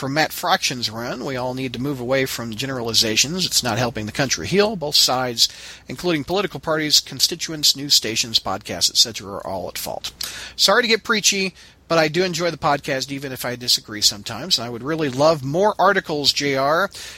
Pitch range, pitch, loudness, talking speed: 125-165 Hz, 140 Hz, -19 LUFS, 190 wpm